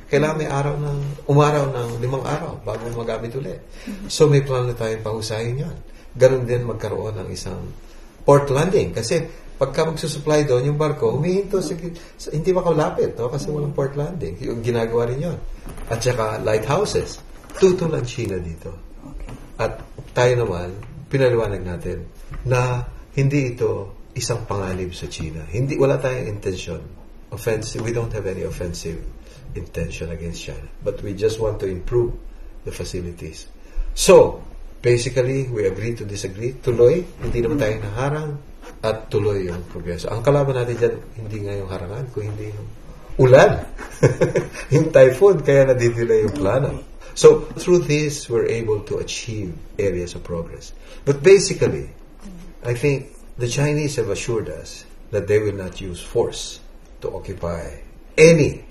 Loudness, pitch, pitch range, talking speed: -20 LUFS, 120 Hz, 100-145 Hz, 145 wpm